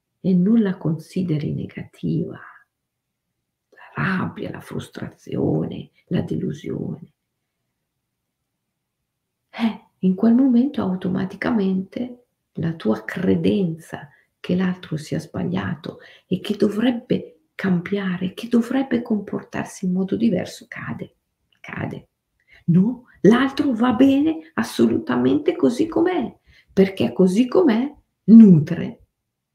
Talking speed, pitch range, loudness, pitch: 95 wpm, 185-245 Hz, -20 LUFS, 205 Hz